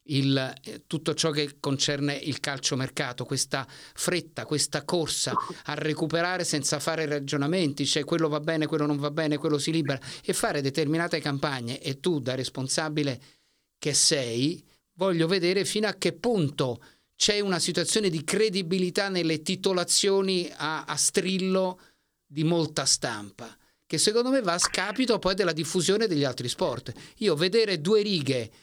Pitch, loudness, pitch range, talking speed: 160 Hz, -26 LUFS, 145-185 Hz, 155 wpm